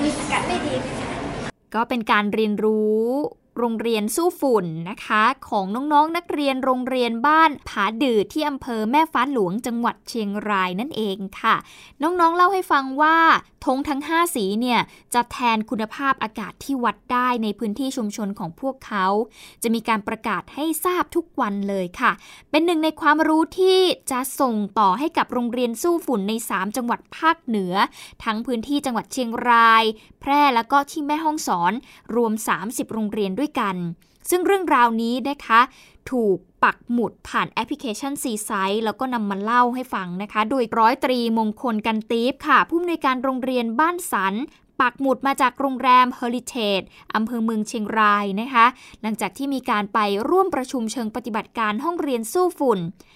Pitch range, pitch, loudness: 220-280 Hz, 240 Hz, -21 LUFS